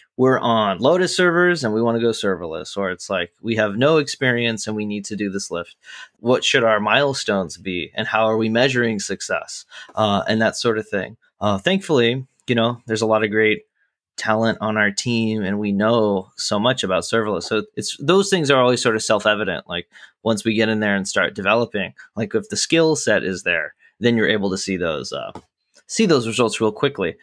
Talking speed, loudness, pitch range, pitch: 215 wpm, -20 LUFS, 105-125 Hz, 110 Hz